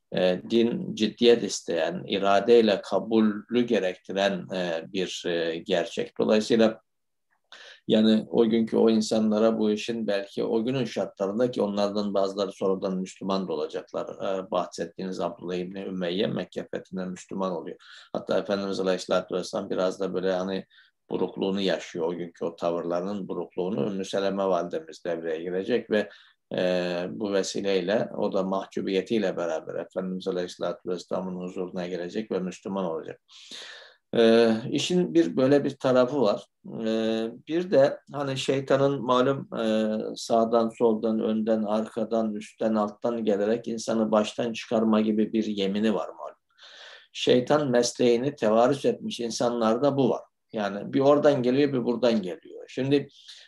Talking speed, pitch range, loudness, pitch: 125 wpm, 95-120 Hz, -26 LUFS, 110 Hz